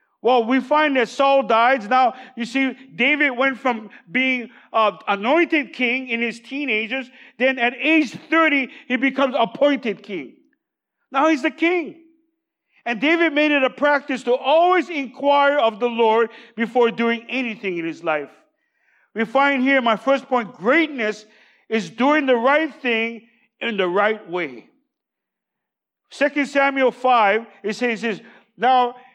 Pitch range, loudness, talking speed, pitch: 230-285 Hz, -19 LUFS, 150 wpm, 255 Hz